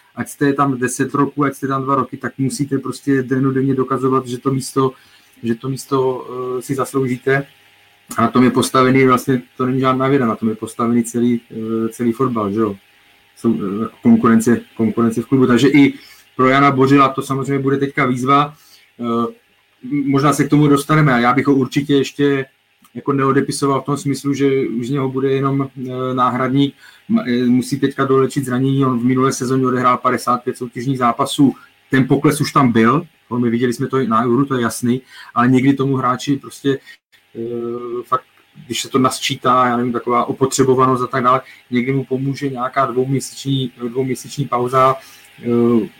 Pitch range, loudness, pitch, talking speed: 120-135 Hz, -17 LUFS, 130 Hz, 175 wpm